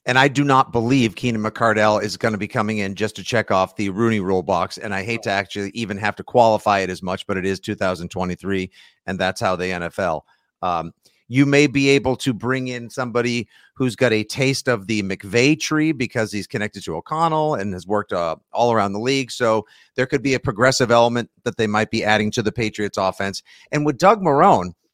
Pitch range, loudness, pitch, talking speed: 100-130 Hz, -20 LUFS, 110 Hz, 220 wpm